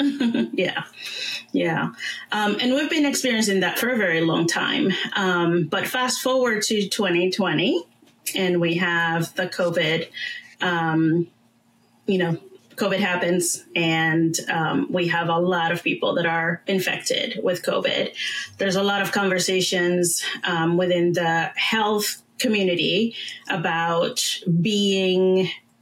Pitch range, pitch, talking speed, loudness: 170-205 Hz, 180 Hz, 125 wpm, -22 LUFS